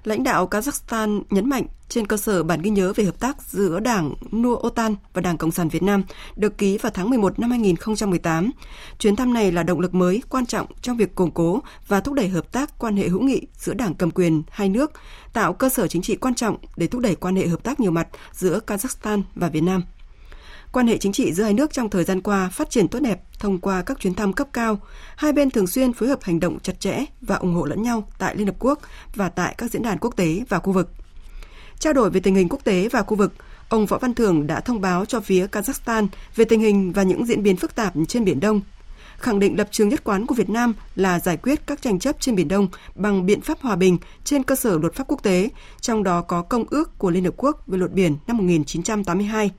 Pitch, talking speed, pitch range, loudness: 205 Hz, 250 wpm, 185-240 Hz, -21 LUFS